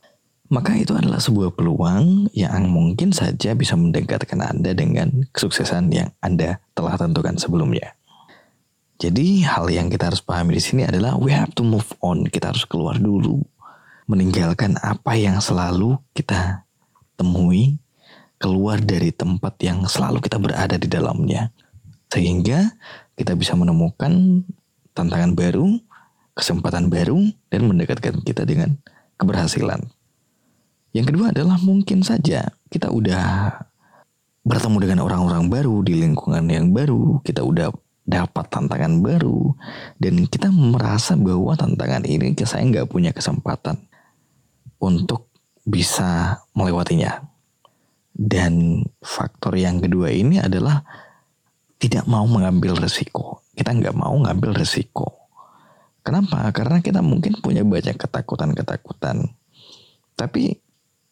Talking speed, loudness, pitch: 120 wpm, -19 LUFS, 120 Hz